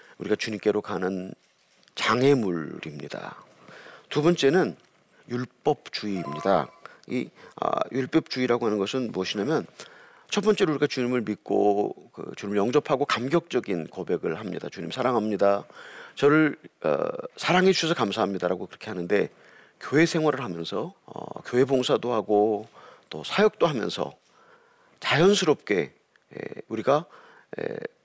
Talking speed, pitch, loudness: 290 characters per minute, 135 Hz, -26 LUFS